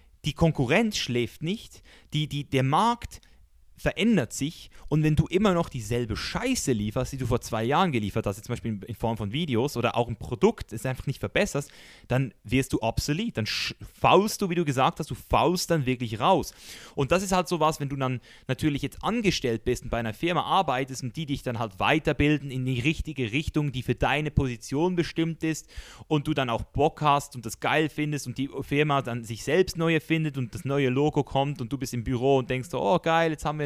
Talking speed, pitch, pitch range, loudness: 225 wpm, 135 Hz, 120-155 Hz, -27 LUFS